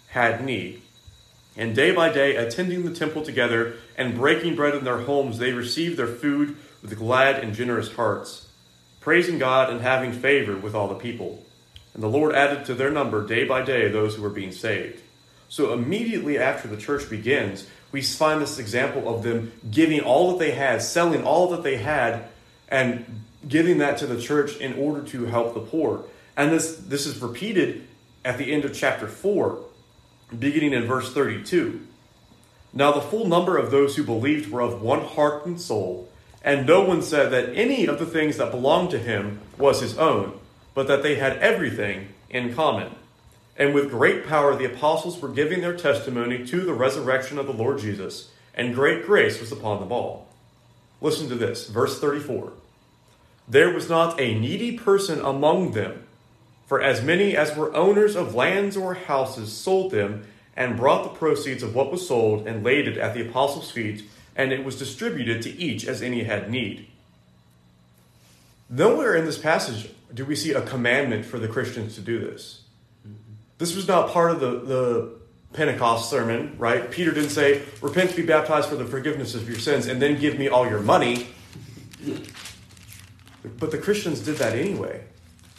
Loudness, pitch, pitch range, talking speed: -23 LUFS, 130 Hz, 115-150 Hz, 180 wpm